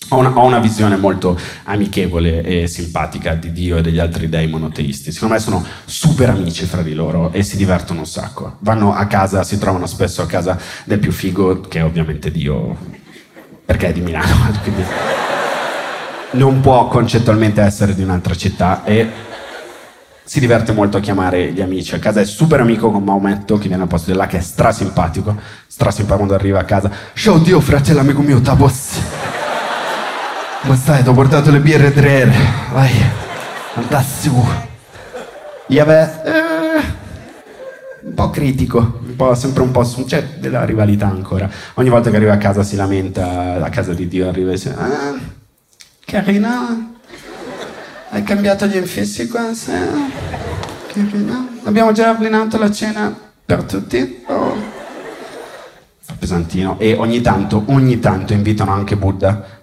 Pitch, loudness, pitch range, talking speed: 105 Hz, -15 LUFS, 95-135 Hz, 160 wpm